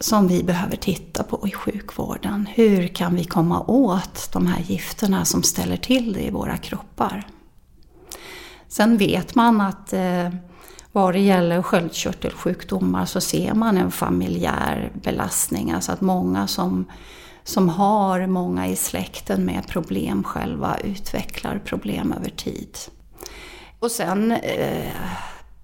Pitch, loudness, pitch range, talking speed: 185 Hz, -22 LUFS, 170-210 Hz, 130 wpm